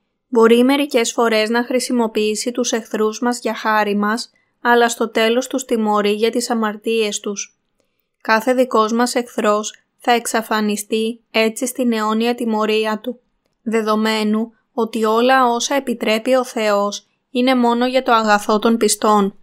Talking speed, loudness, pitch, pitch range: 140 wpm, -17 LUFS, 230 Hz, 215-245 Hz